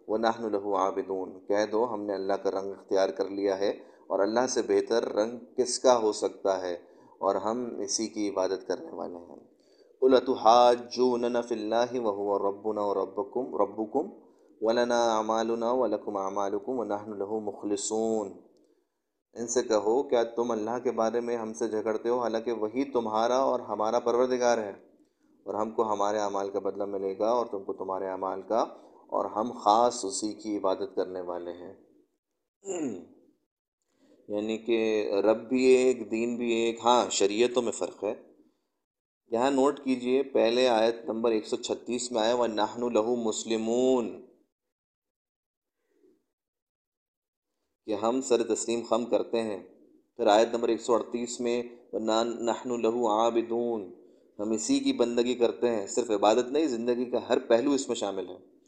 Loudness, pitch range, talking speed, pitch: -28 LUFS, 105-120 Hz, 160 wpm, 115 Hz